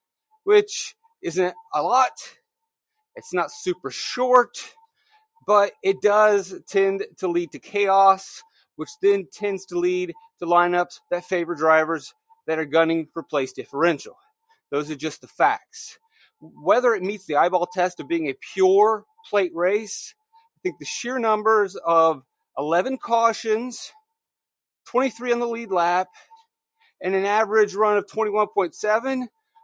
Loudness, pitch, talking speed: -22 LUFS, 215 Hz, 140 wpm